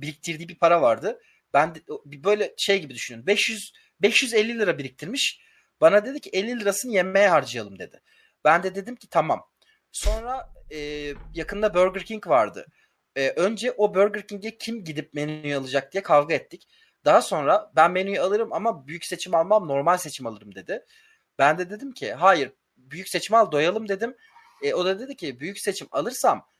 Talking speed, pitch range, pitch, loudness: 170 wpm, 160-230 Hz, 200 Hz, -23 LUFS